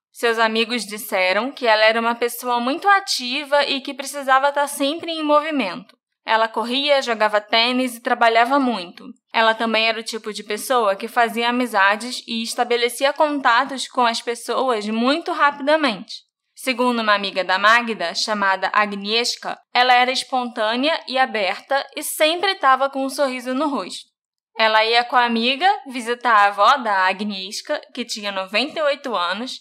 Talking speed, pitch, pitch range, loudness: 155 wpm, 245 Hz, 220-275 Hz, -19 LUFS